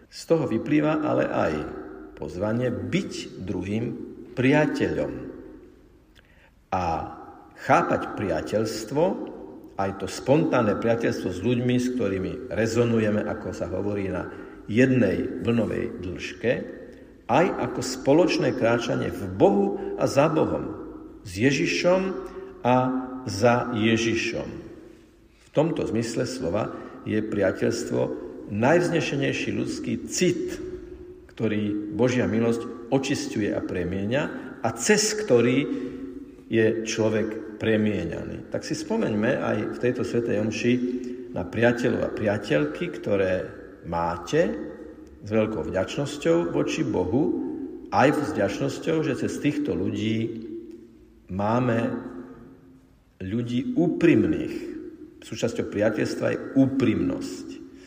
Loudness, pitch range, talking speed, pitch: -25 LUFS, 110-155 Hz, 100 wpm, 120 Hz